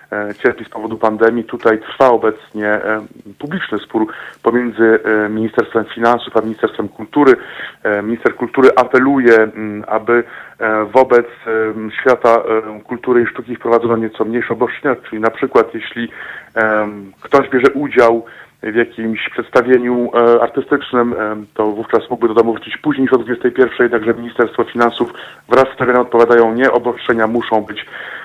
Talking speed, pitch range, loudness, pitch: 125 wpm, 110-120 Hz, -14 LUFS, 115 Hz